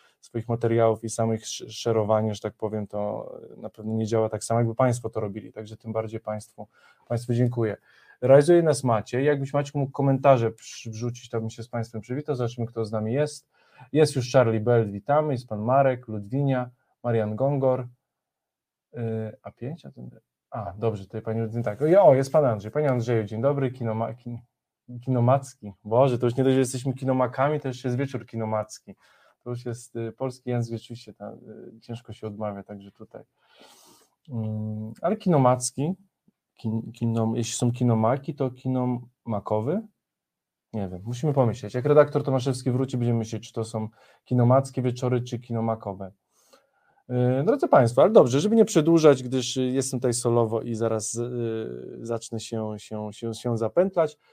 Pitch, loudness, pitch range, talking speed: 120 Hz, -25 LUFS, 110-130 Hz, 160 wpm